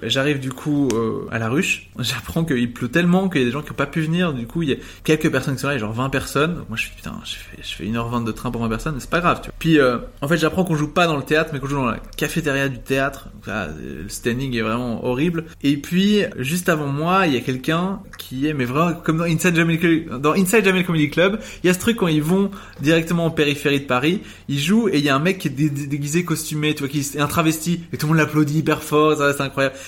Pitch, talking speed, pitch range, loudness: 150 Hz, 290 wpm, 130-165 Hz, -20 LUFS